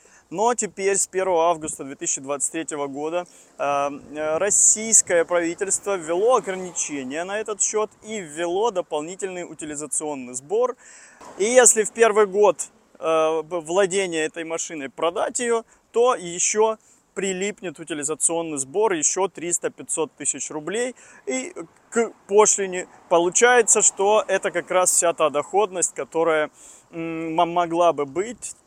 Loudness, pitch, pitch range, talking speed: -21 LUFS, 175 Hz, 160-210 Hz, 110 wpm